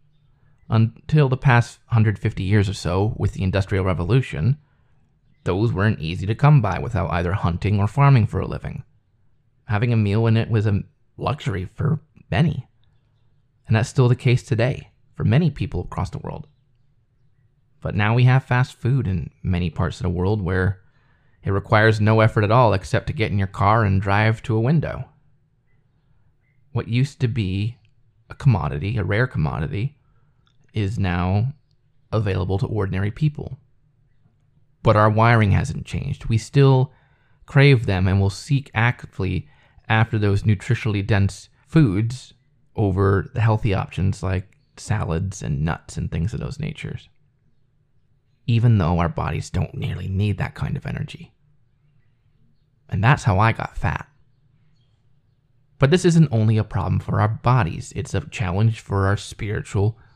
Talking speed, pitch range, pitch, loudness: 155 wpm, 105-135 Hz, 120 Hz, -21 LUFS